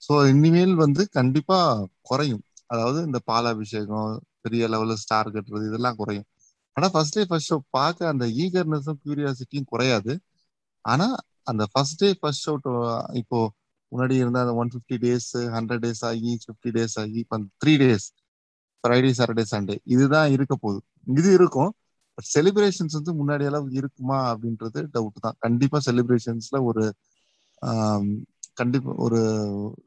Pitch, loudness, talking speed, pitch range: 125 Hz, -23 LUFS, 135 wpm, 115-145 Hz